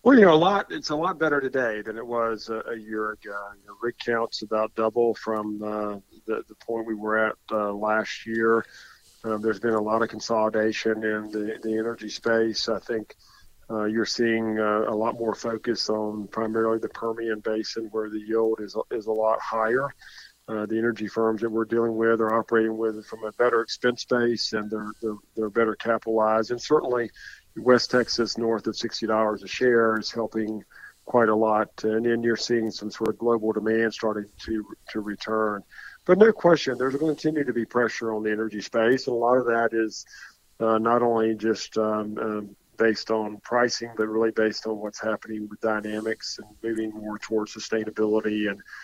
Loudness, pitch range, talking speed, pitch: -25 LUFS, 110-115 Hz, 200 wpm, 110 Hz